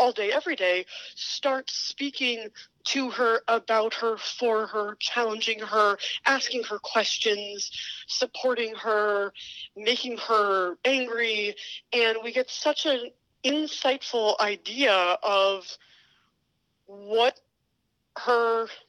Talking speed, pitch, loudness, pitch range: 100 wpm, 230 Hz, -26 LUFS, 210-250 Hz